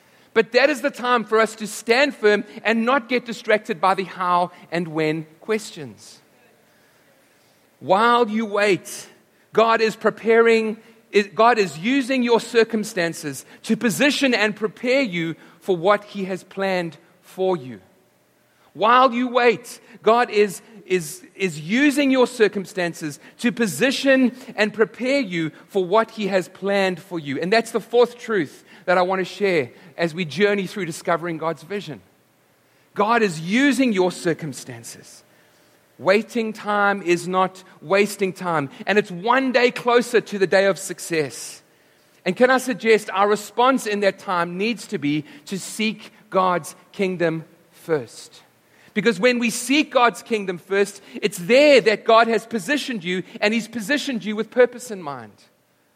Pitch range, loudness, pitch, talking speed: 180-230 Hz, -20 LUFS, 205 Hz, 150 wpm